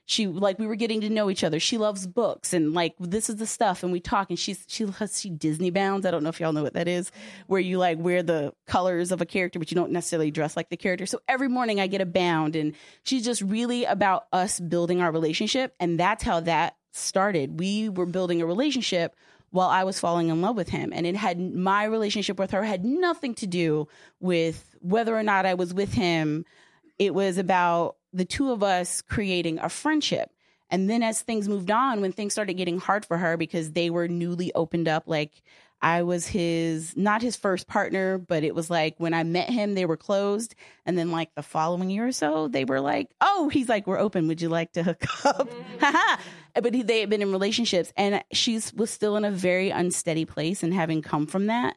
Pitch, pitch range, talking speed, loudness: 185 Hz, 170-210 Hz, 230 wpm, -26 LUFS